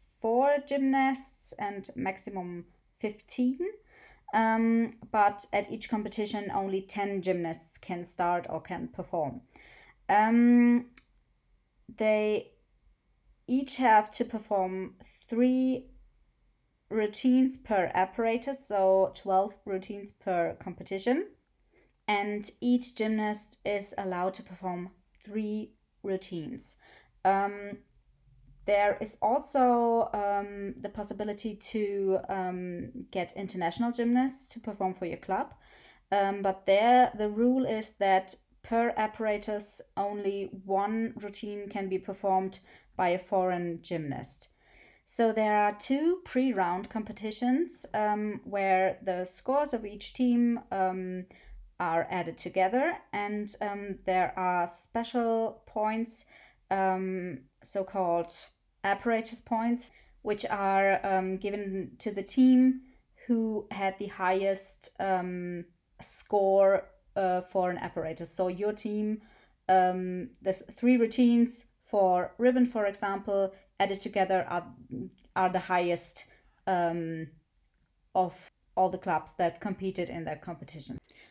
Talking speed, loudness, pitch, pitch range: 110 wpm, -30 LUFS, 205 Hz, 185-230 Hz